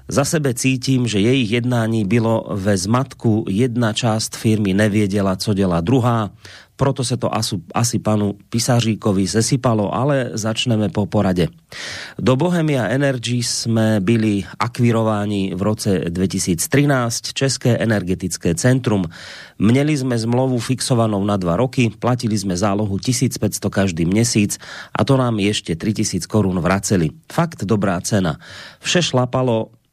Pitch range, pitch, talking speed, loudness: 100-125 Hz, 110 Hz, 130 wpm, -18 LUFS